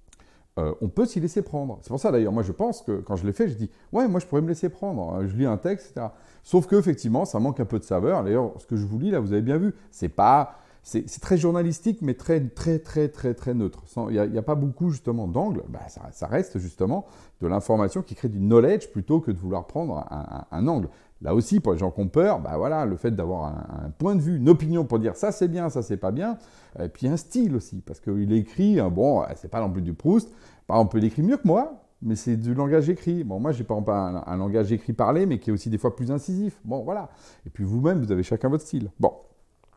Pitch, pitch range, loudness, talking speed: 120 Hz, 100-170 Hz, -25 LUFS, 265 wpm